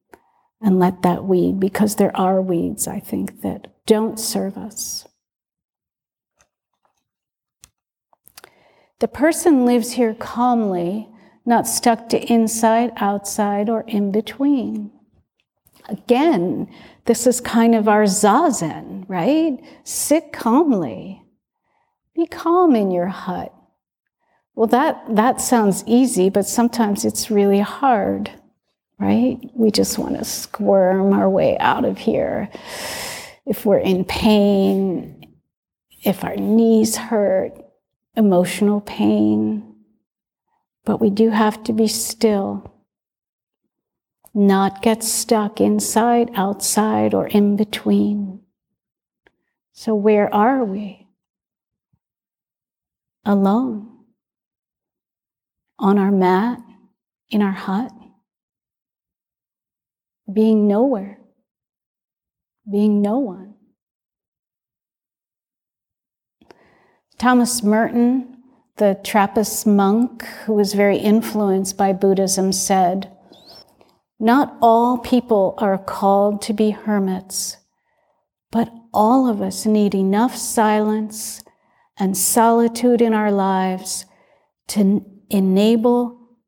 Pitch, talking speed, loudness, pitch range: 215 Hz, 95 wpm, -18 LUFS, 195-235 Hz